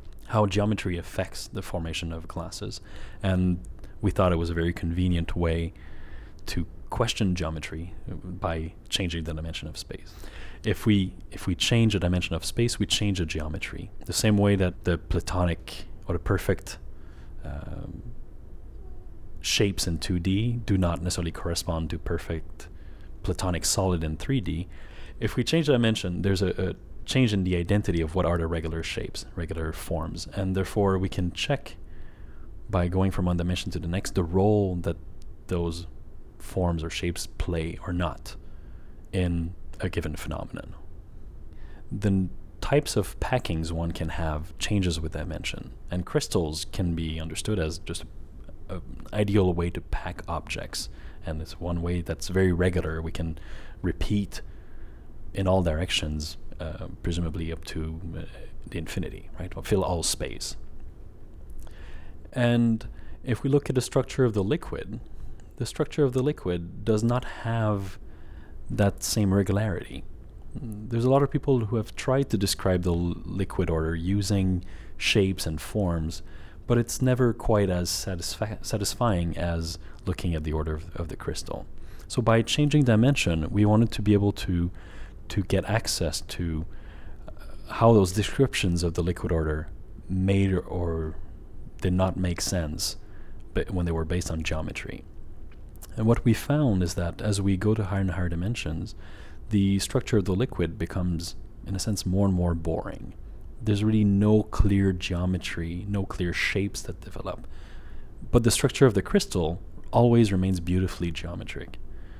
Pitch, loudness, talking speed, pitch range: 90 Hz, -27 LUFS, 160 wpm, 85-100 Hz